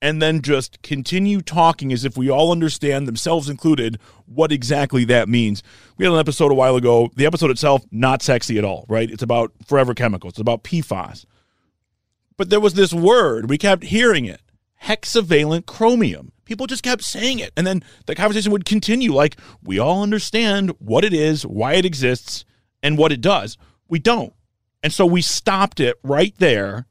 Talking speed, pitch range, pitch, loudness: 185 wpm, 115-185 Hz, 145 Hz, -18 LUFS